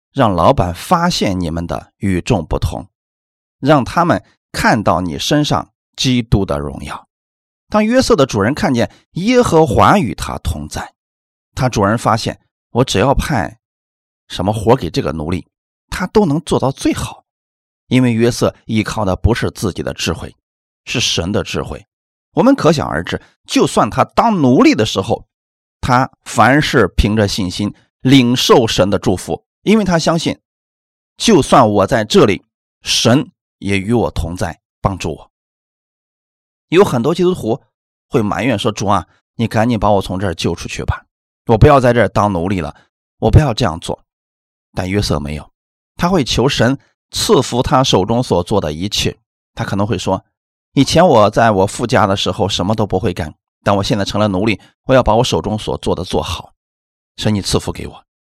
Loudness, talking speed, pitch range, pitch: -15 LUFS, 245 characters per minute, 85-125 Hz, 105 Hz